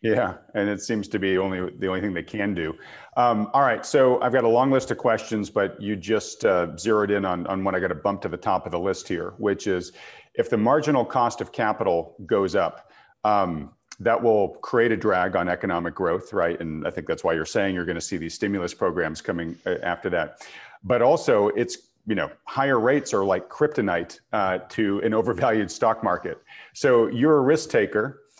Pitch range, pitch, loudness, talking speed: 90-110 Hz, 100 Hz, -24 LUFS, 215 wpm